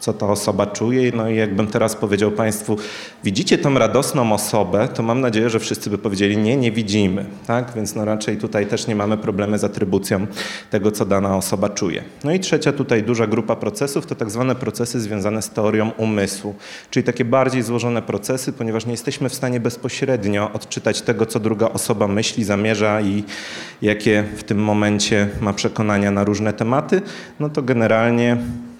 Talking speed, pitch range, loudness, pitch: 180 wpm, 105-120 Hz, -19 LUFS, 110 Hz